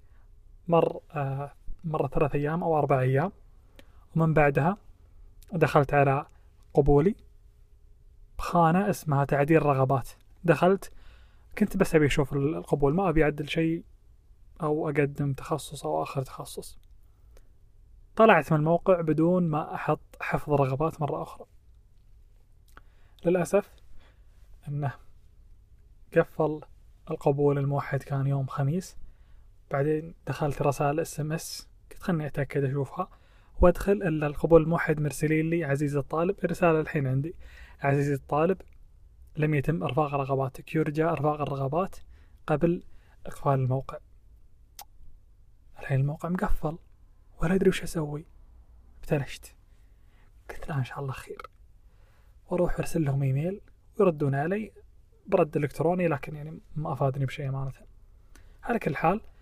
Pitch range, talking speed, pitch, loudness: 105-165 Hz, 115 wpm, 145 Hz, -27 LUFS